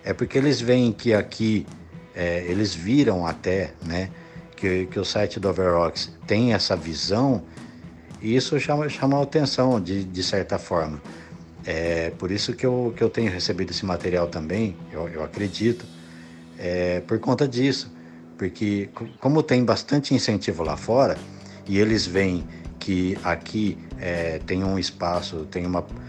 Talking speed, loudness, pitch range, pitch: 155 wpm, -24 LUFS, 85-115 Hz, 95 Hz